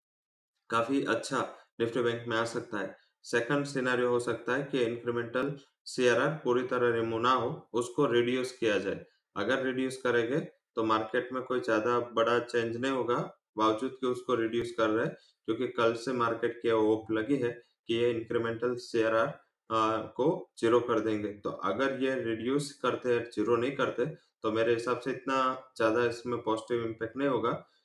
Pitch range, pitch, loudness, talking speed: 115-130 Hz, 120 Hz, -31 LUFS, 170 wpm